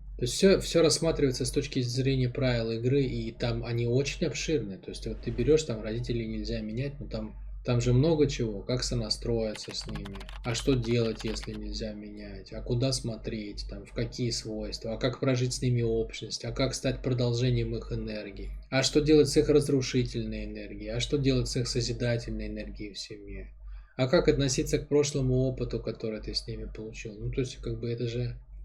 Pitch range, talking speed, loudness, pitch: 110-135 Hz, 195 wpm, -29 LUFS, 120 Hz